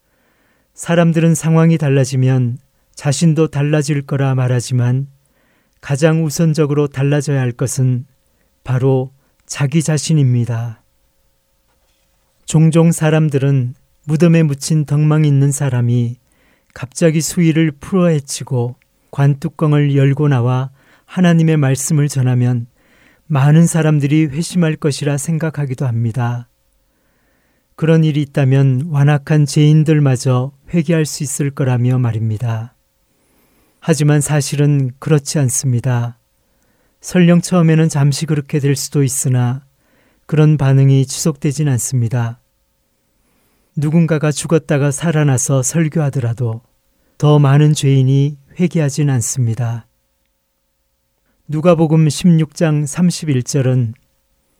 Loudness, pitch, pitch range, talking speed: -15 LUFS, 140 Hz, 125-155 Hz, 245 characters per minute